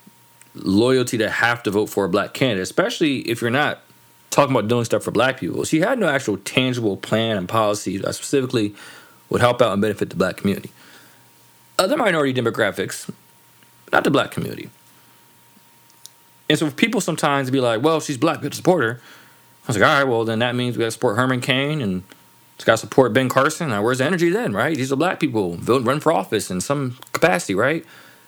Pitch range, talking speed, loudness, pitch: 115-140 Hz, 205 wpm, -20 LUFS, 125 Hz